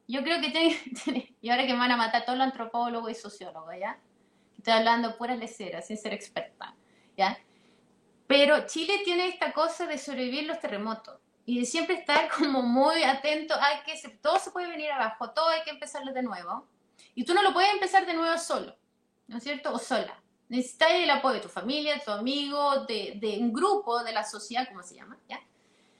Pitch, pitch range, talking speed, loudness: 265 Hz, 230-310 Hz, 210 wpm, -28 LUFS